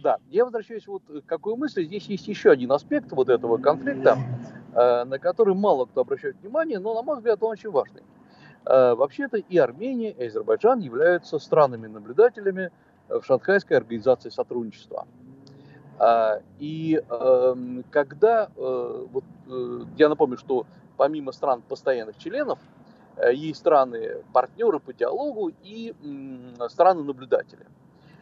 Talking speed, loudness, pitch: 120 wpm, -23 LUFS, 195 Hz